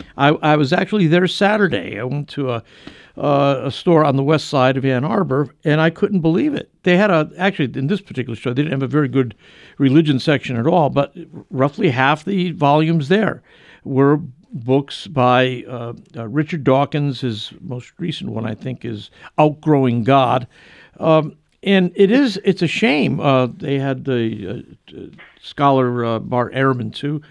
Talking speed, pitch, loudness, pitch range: 180 wpm, 145 Hz, -17 LUFS, 130-170 Hz